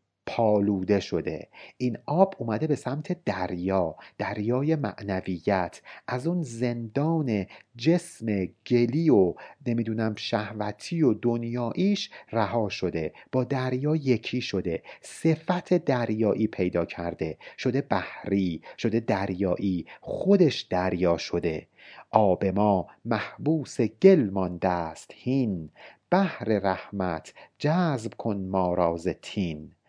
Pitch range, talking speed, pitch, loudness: 95-135 Hz, 100 wpm, 110 Hz, -27 LUFS